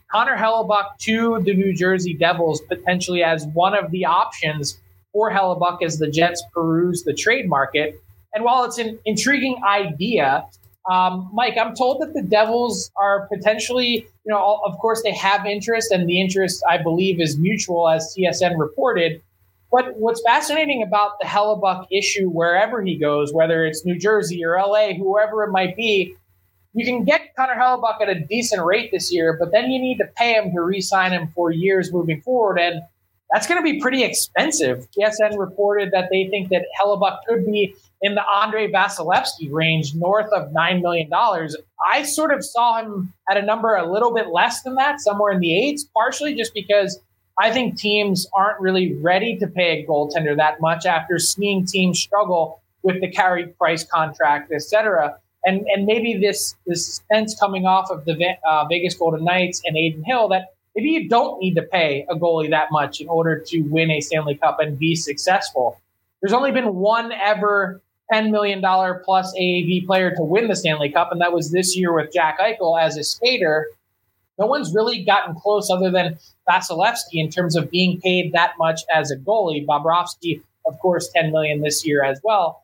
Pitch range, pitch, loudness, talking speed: 165-215 Hz, 185 Hz, -19 LUFS, 185 wpm